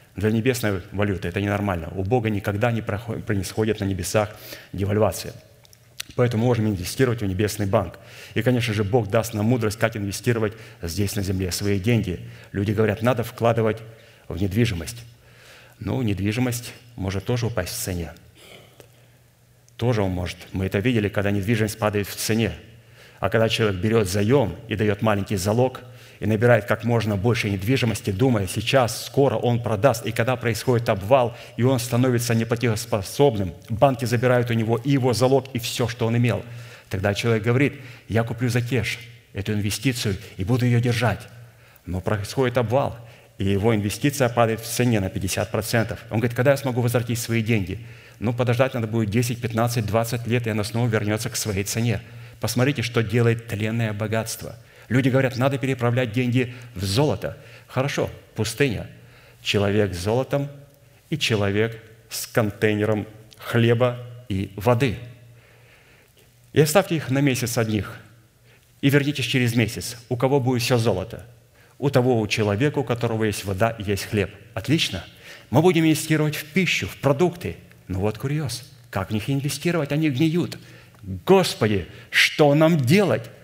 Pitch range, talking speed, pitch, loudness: 105-125 Hz, 155 wpm, 115 Hz, -23 LUFS